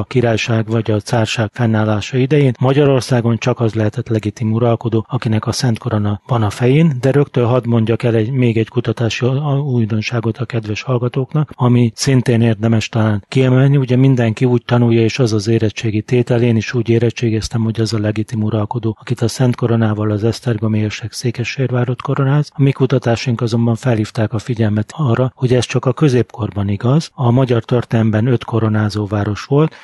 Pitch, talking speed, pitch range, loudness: 115 Hz, 175 wpm, 110-125 Hz, -15 LUFS